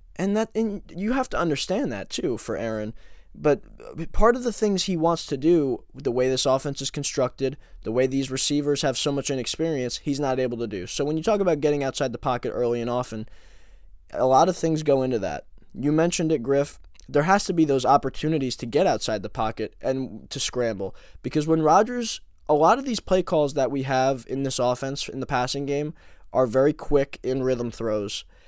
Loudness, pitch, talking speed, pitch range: -24 LUFS, 140 Hz, 215 wpm, 125-160 Hz